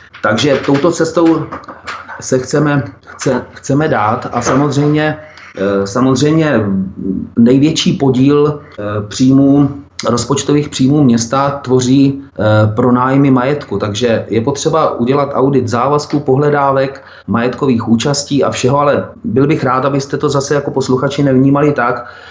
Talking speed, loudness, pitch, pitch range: 115 wpm, -12 LUFS, 135 Hz, 120-145 Hz